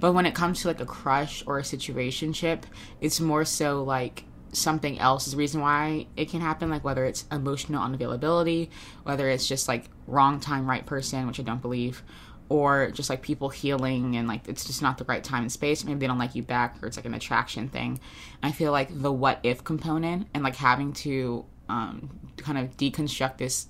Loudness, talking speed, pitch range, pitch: -27 LUFS, 215 wpm, 125-150 Hz, 135 Hz